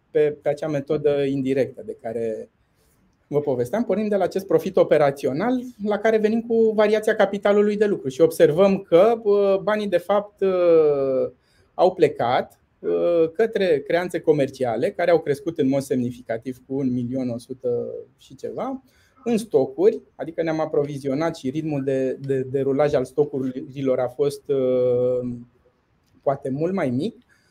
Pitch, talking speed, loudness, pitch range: 150 Hz, 135 wpm, -22 LUFS, 130-205 Hz